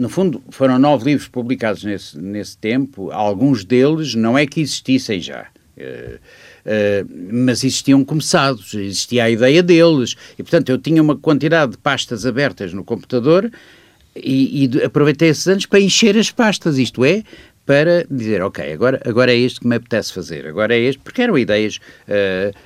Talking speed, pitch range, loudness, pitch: 170 wpm, 110-150 Hz, -16 LUFS, 130 Hz